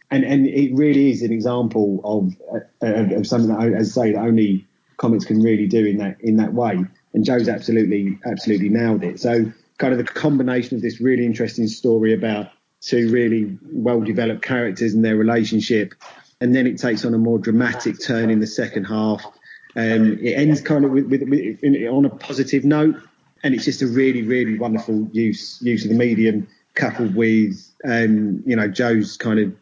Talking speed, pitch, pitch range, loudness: 200 wpm, 115 Hz, 110-125 Hz, -19 LUFS